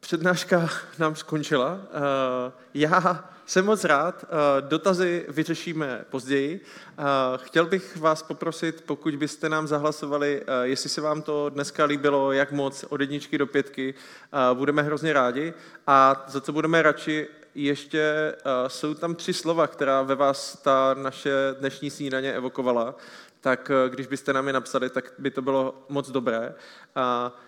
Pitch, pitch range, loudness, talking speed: 145 Hz, 135-155 Hz, -25 LUFS, 140 wpm